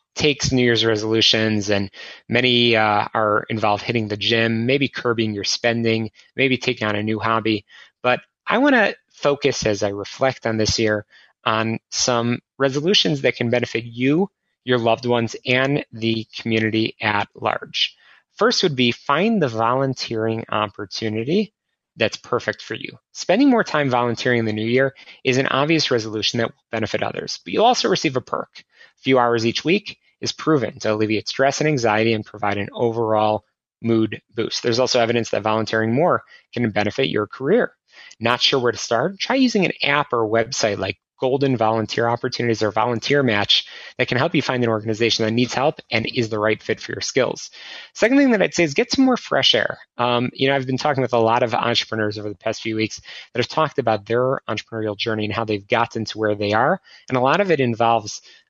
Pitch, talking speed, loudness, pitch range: 115 Hz, 200 wpm, -20 LUFS, 110-135 Hz